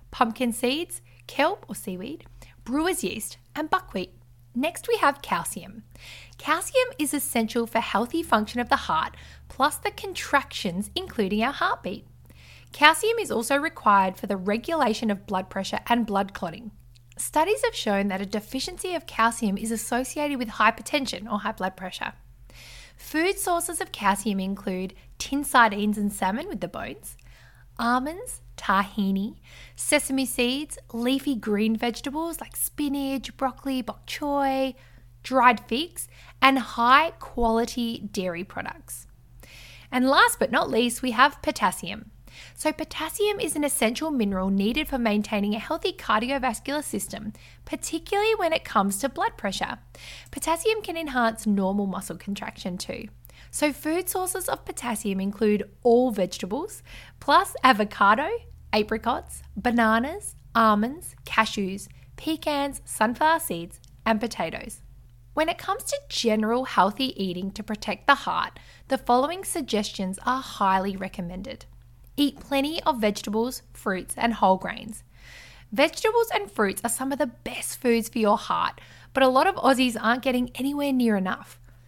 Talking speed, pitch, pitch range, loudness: 140 wpm, 230 Hz, 200-285 Hz, -25 LUFS